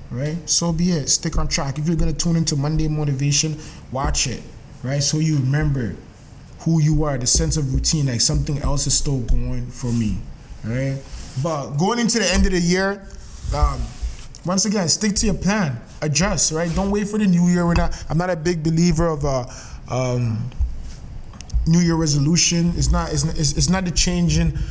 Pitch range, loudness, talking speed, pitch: 135-170 Hz, -20 LUFS, 195 wpm, 155 Hz